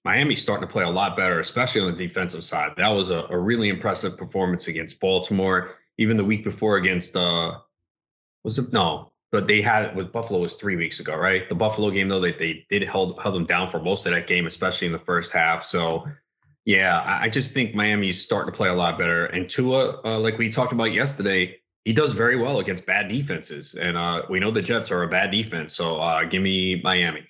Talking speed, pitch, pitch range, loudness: 230 wpm, 95 Hz, 90-110 Hz, -22 LUFS